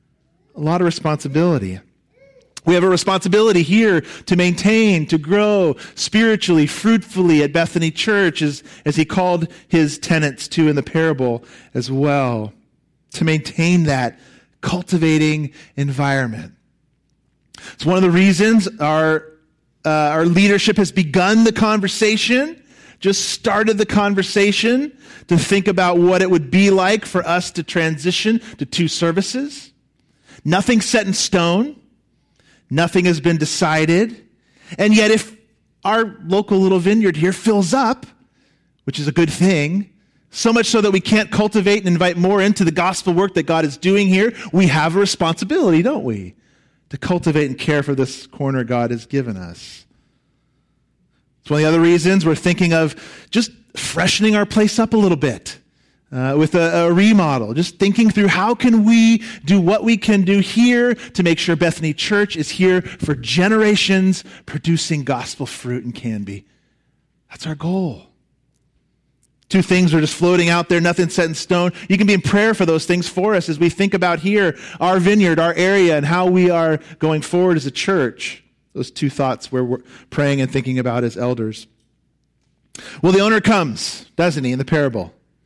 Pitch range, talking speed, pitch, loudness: 155-200 Hz, 165 wpm, 175 Hz, -16 LUFS